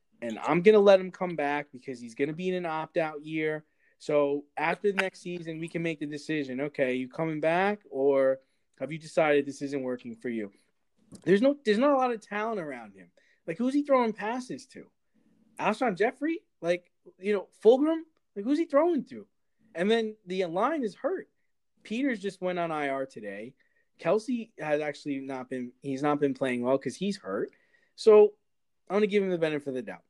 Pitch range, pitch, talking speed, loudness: 145-225 Hz, 175 Hz, 200 wpm, -28 LUFS